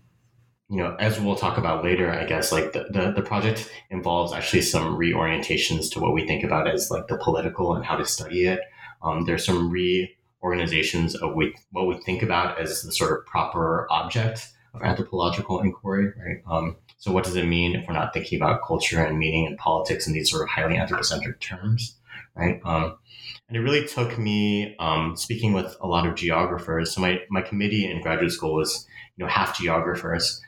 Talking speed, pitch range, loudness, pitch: 195 wpm, 85-105 Hz, -24 LUFS, 95 Hz